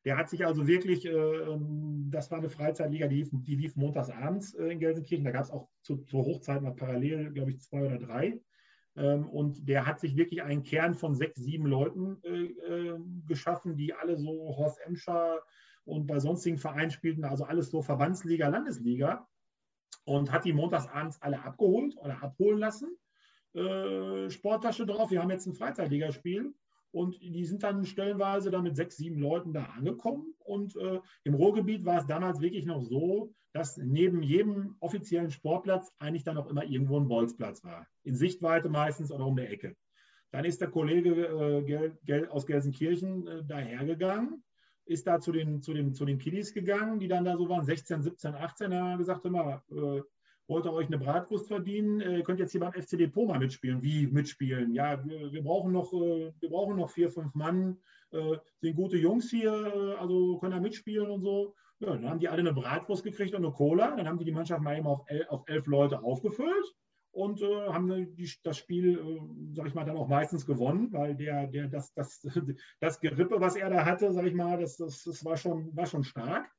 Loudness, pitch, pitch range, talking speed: -32 LUFS, 165 Hz, 145-180 Hz, 195 wpm